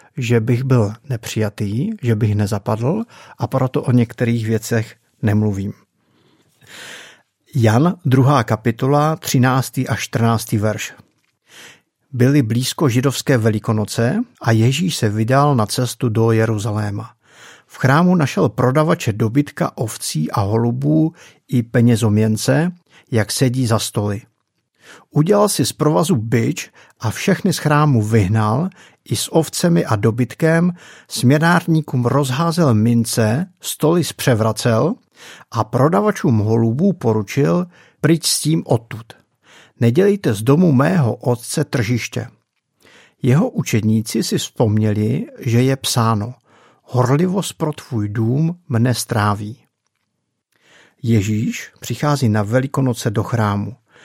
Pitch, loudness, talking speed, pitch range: 125 Hz, -17 LUFS, 110 wpm, 115-150 Hz